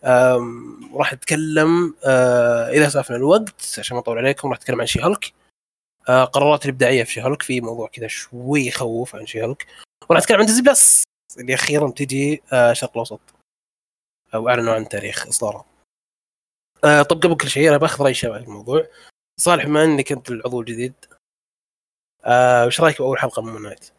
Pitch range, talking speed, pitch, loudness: 120-150 Hz, 175 wpm, 130 Hz, -17 LUFS